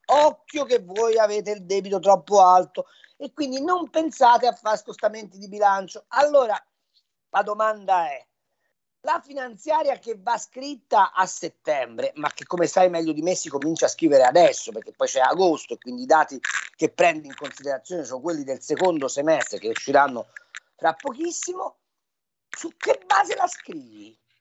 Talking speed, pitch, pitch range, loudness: 160 wpm, 220 Hz, 180-300 Hz, -22 LUFS